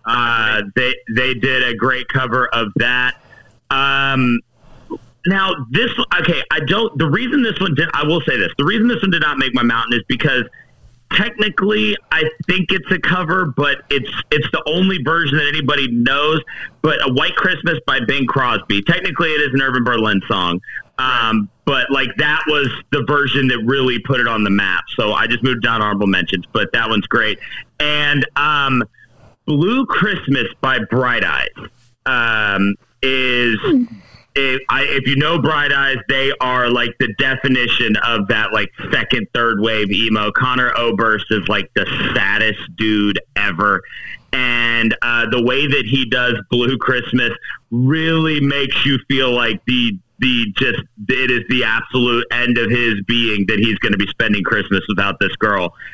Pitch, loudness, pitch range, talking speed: 130 Hz, -16 LUFS, 115-150 Hz, 170 wpm